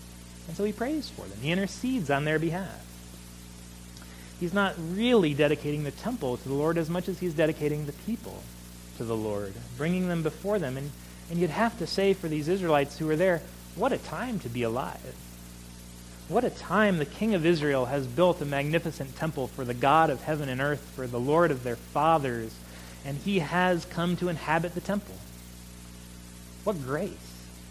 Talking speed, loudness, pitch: 190 wpm, -28 LUFS, 145 Hz